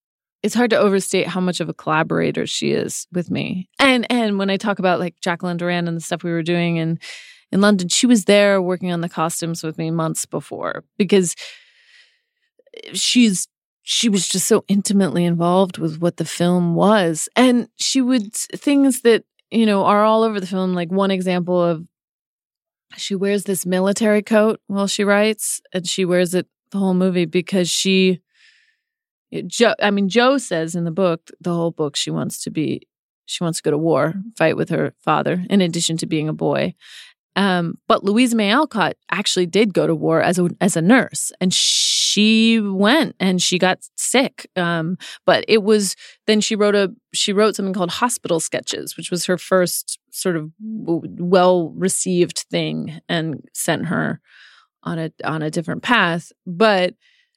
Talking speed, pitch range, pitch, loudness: 180 wpm, 175-215 Hz, 190 Hz, -18 LUFS